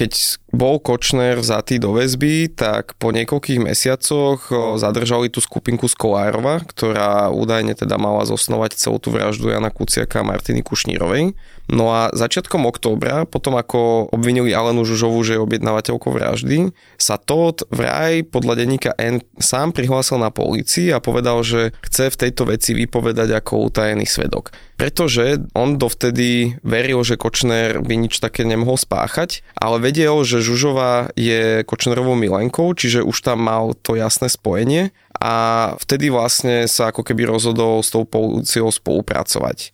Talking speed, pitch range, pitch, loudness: 145 wpm, 110-130 Hz, 120 Hz, -17 LUFS